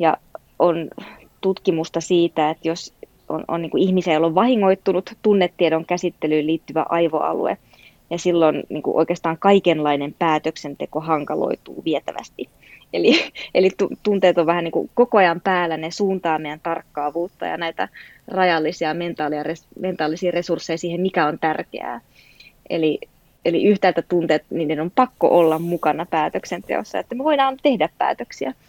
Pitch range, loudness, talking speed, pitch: 160-185 Hz, -20 LUFS, 130 wpm, 170 Hz